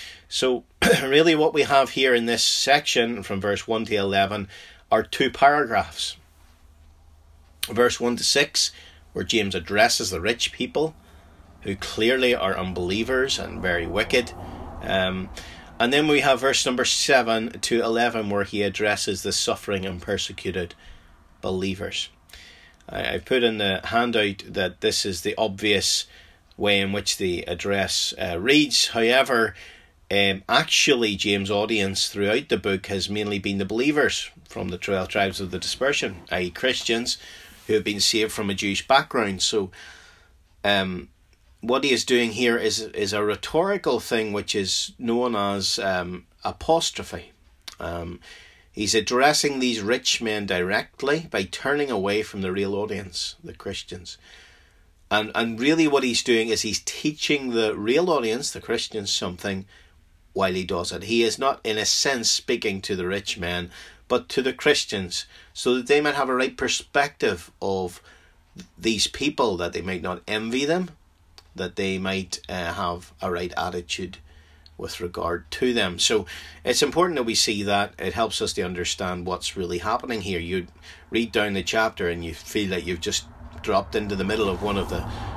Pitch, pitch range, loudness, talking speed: 100 Hz, 90-110 Hz, -23 LUFS, 165 wpm